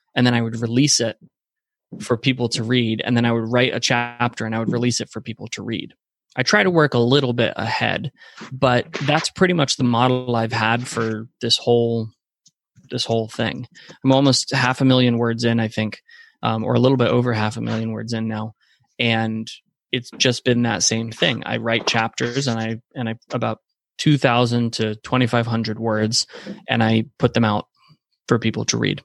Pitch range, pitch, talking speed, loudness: 115-125 Hz, 120 Hz, 200 wpm, -20 LUFS